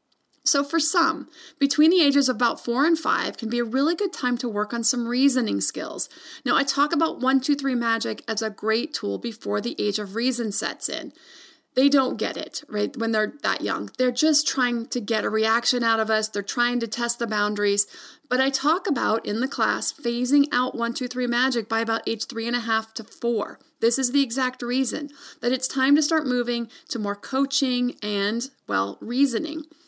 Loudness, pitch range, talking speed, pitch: -23 LUFS, 225-280 Hz, 215 wpm, 245 Hz